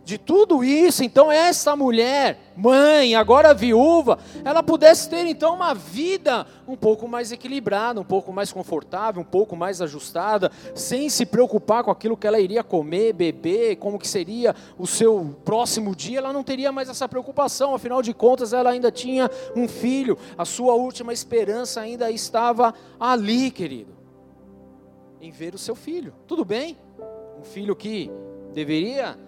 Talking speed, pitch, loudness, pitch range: 160 wpm, 235 Hz, -20 LUFS, 200-270 Hz